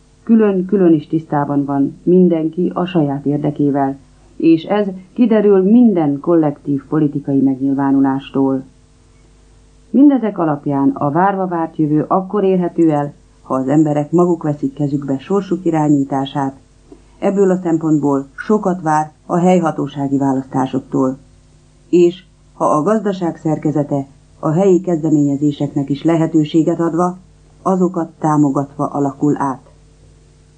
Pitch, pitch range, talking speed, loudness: 150 Hz, 140-175 Hz, 110 wpm, -15 LUFS